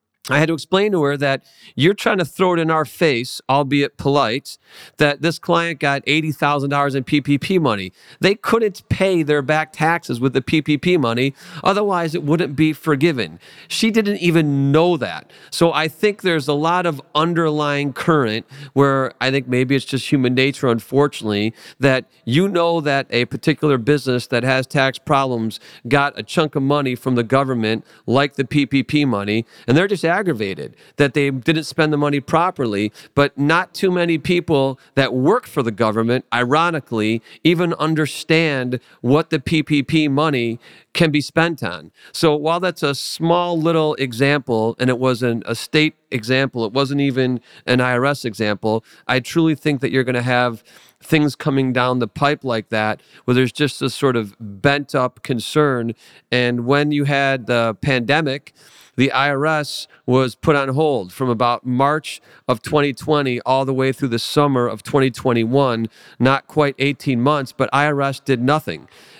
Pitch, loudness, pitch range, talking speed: 140 Hz, -18 LUFS, 125-155 Hz, 170 wpm